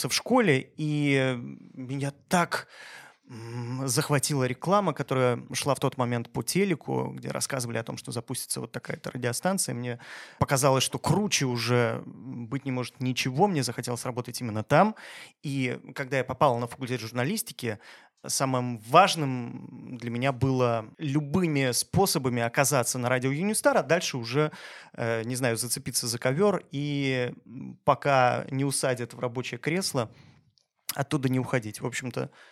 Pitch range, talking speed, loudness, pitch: 125-145 Hz, 140 wpm, -27 LUFS, 130 Hz